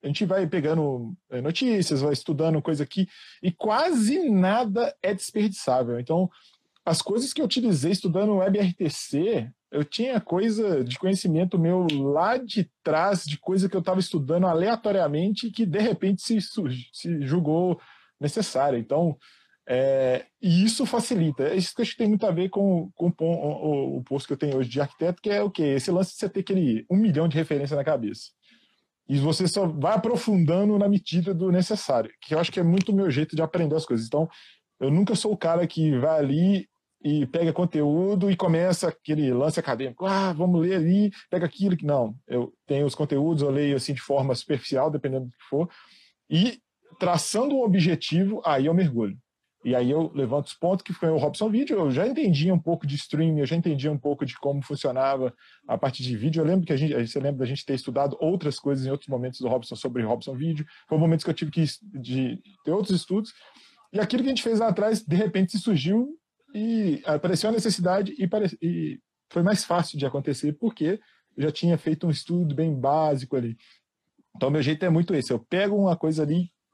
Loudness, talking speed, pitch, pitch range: -25 LUFS, 205 wpm, 170 Hz, 145-195 Hz